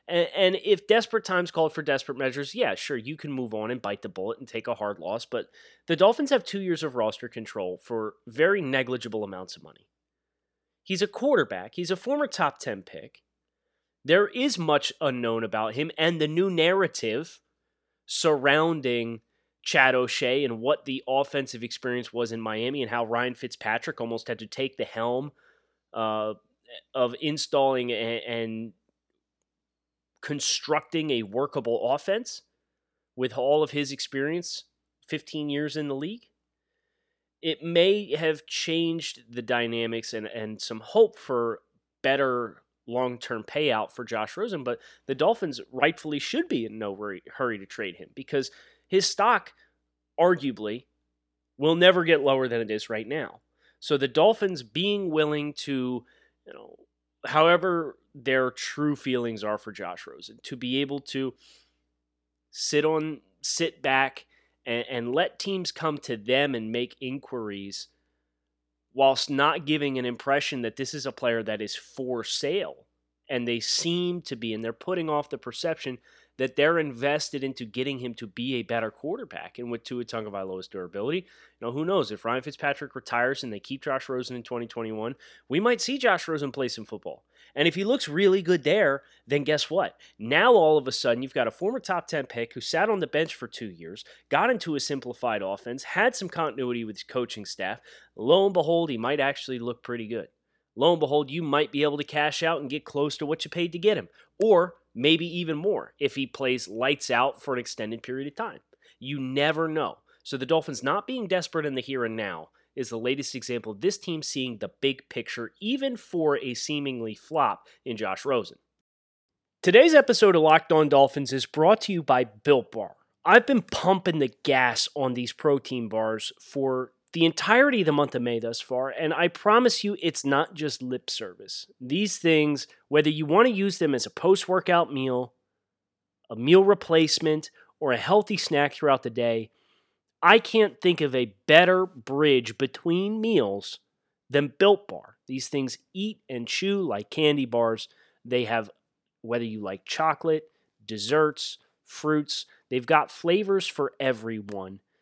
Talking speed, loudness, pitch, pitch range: 175 wpm, -26 LUFS, 140 Hz, 120-160 Hz